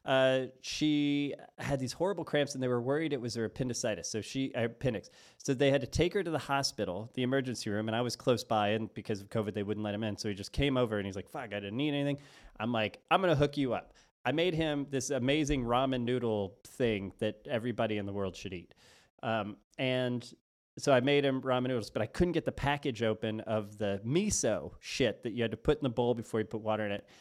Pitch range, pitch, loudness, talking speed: 110-140 Hz, 125 Hz, -33 LUFS, 245 wpm